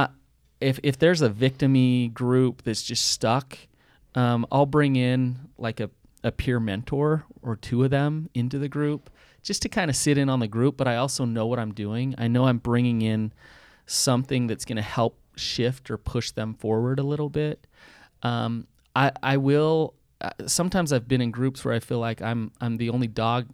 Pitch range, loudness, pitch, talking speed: 115-140 Hz, -25 LUFS, 125 Hz, 195 wpm